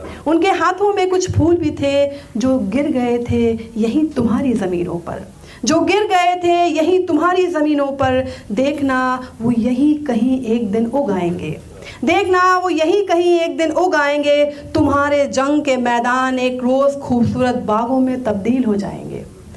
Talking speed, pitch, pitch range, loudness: 150 wpm, 275 Hz, 240-320 Hz, -16 LUFS